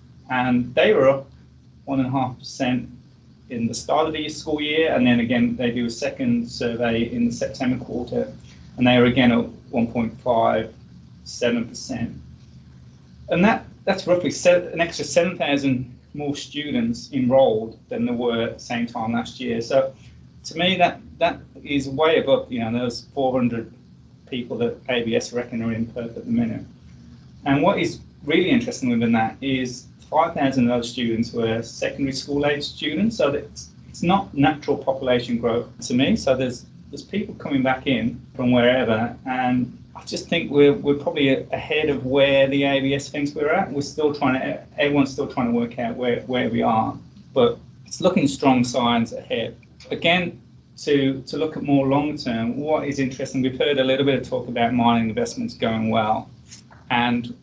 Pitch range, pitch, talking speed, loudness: 120-145 Hz, 130 Hz, 180 wpm, -22 LUFS